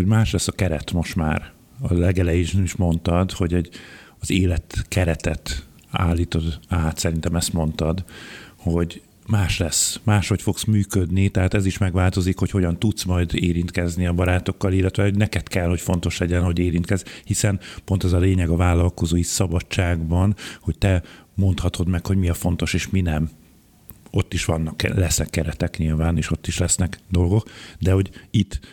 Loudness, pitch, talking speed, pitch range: -22 LUFS, 90 Hz, 165 wpm, 85-95 Hz